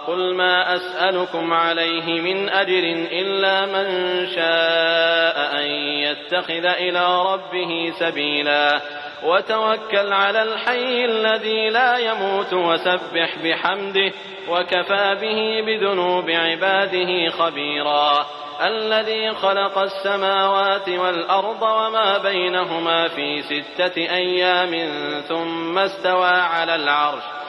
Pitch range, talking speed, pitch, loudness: 165-195 Hz, 85 wpm, 180 Hz, -19 LUFS